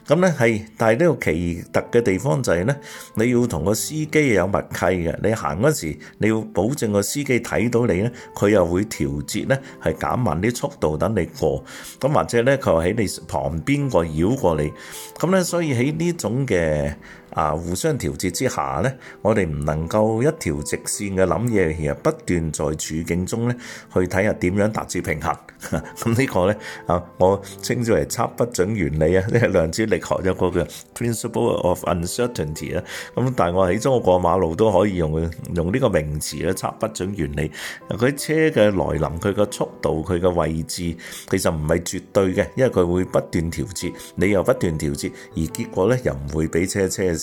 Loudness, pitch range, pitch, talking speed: -21 LUFS, 80-115 Hz, 95 Hz, 300 characters per minute